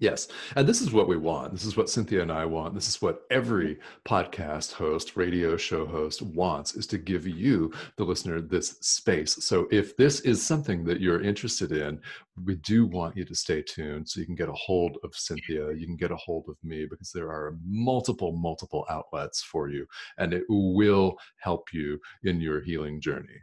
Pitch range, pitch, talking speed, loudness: 80-95 Hz, 85 Hz, 205 wpm, -28 LUFS